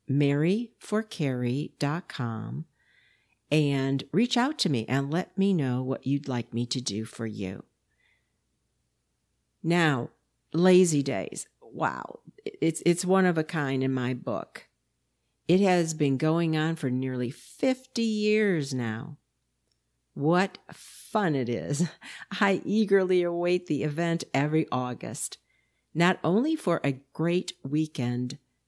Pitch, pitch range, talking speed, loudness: 155 Hz, 130-180 Hz, 120 wpm, -27 LUFS